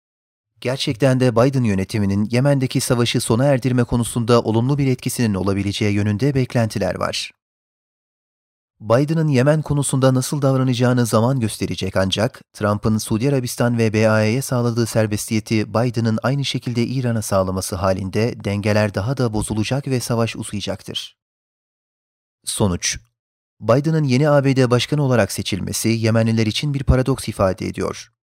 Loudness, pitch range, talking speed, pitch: -19 LUFS, 105-130 Hz, 120 wpm, 115 Hz